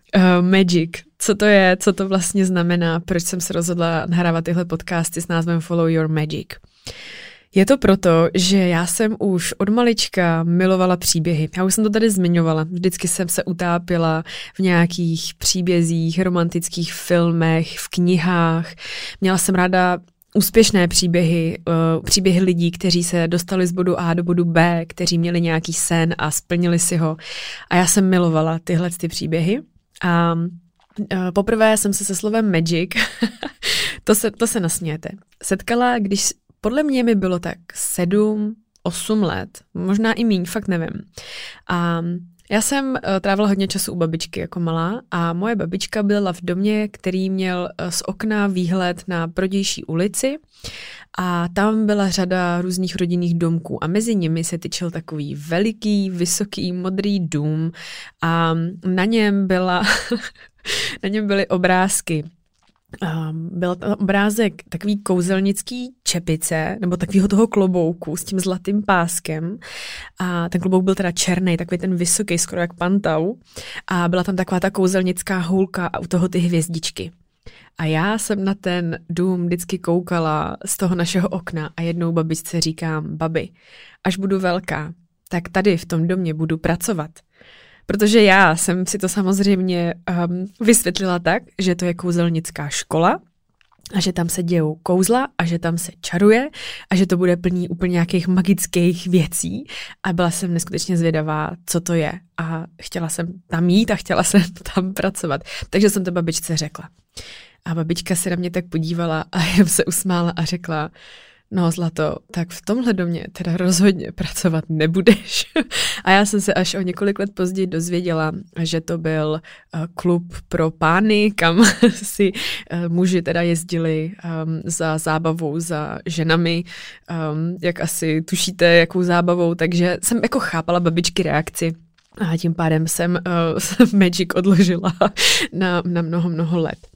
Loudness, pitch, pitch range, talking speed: -19 LUFS, 180 Hz, 170-195 Hz, 155 wpm